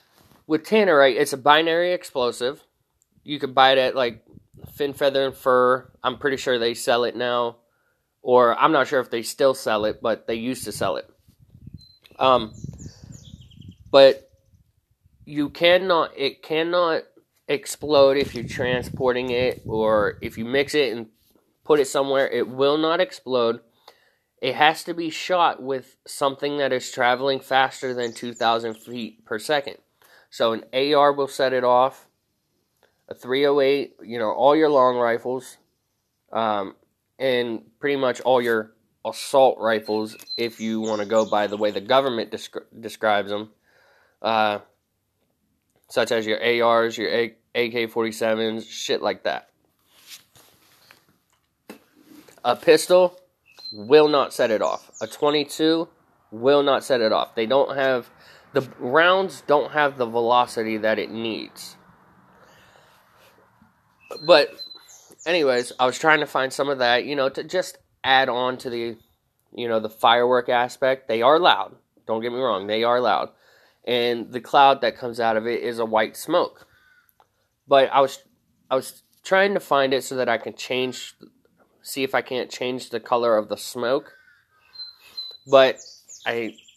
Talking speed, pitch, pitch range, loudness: 155 wpm, 125 Hz, 115-140 Hz, -21 LUFS